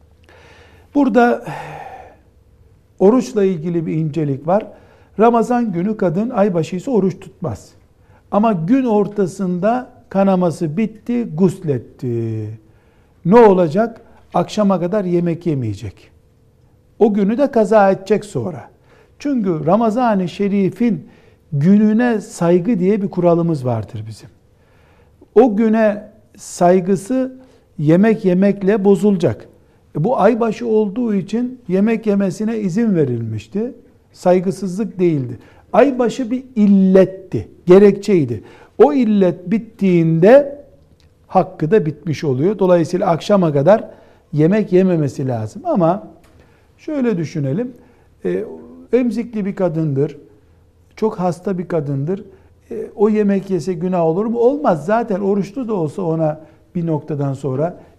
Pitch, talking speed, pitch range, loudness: 190 Hz, 100 wpm, 155-215 Hz, -16 LUFS